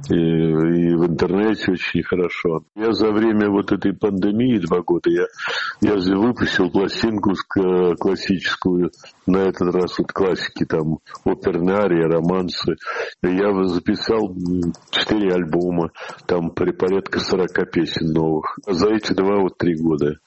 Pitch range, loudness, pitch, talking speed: 85-105 Hz, -20 LUFS, 90 Hz, 135 wpm